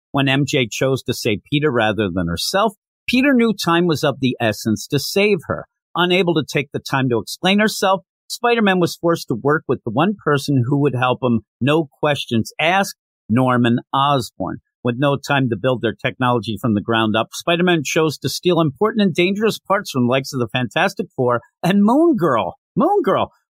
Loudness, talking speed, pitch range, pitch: -18 LUFS, 195 wpm, 125-175 Hz, 140 Hz